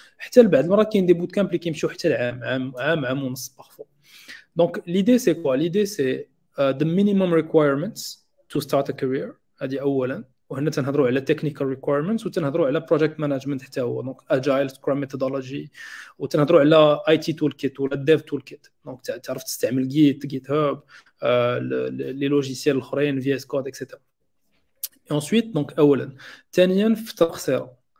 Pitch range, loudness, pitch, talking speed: 135-170 Hz, -22 LUFS, 145 Hz, 155 wpm